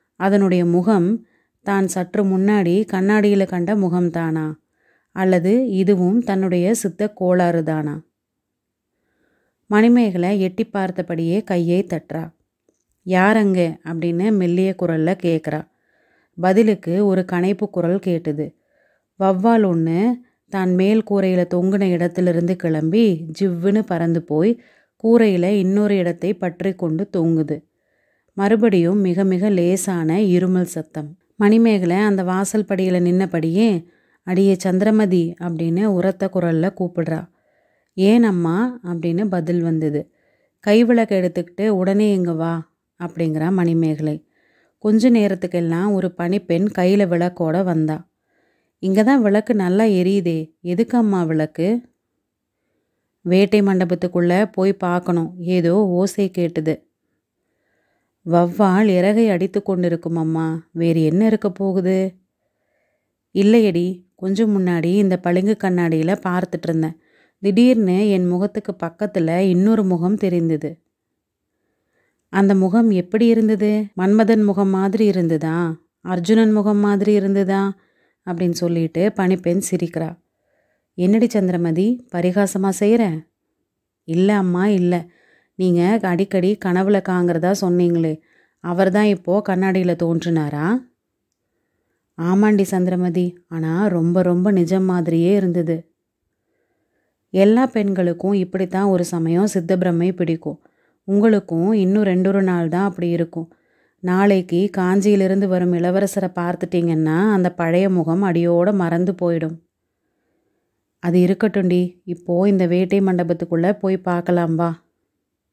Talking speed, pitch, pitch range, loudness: 105 wpm, 185 Hz, 175-200 Hz, -18 LUFS